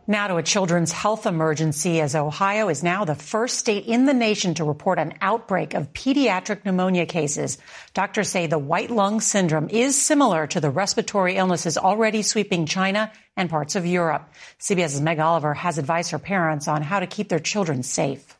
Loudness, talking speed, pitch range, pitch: -22 LUFS, 185 wpm, 160-210 Hz, 185 Hz